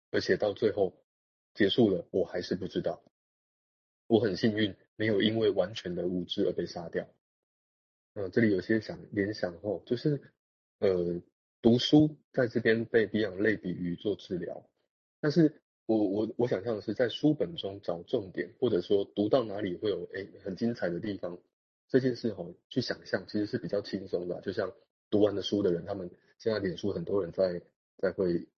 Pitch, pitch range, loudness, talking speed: 105 Hz, 90-120 Hz, -31 LUFS, 270 characters per minute